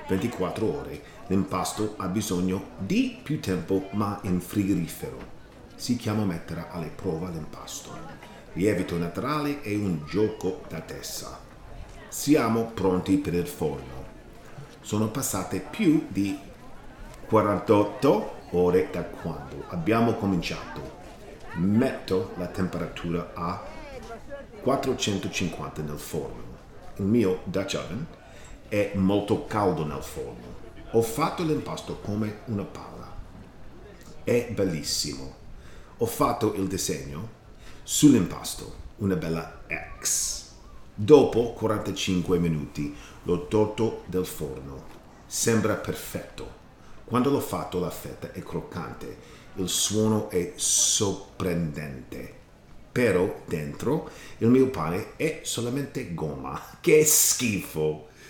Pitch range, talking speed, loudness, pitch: 90-115 Hz, 105 wpm, -26 LUFS, 100 Hz